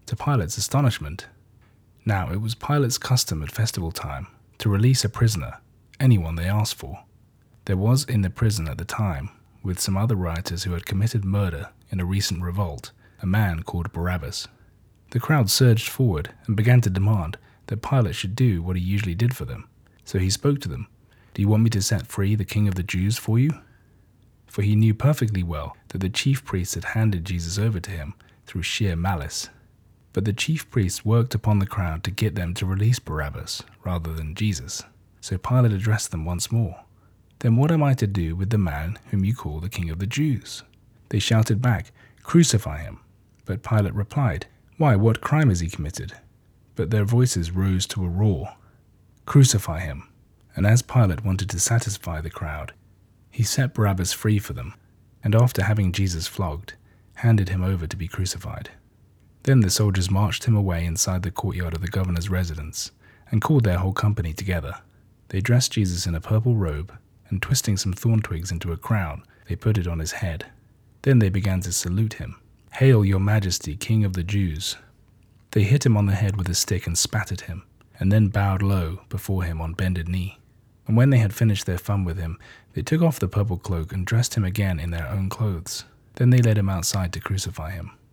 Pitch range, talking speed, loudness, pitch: 95-115 Hz, 200 wpm, -23 LUFS, 105 Hz